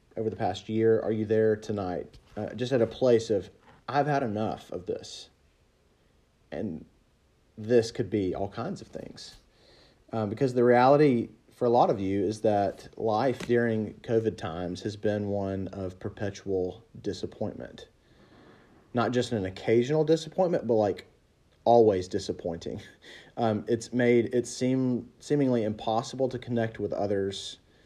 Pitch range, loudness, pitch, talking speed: 100-120 Hz, -28 LUFS, 110 Hz, 145 wpm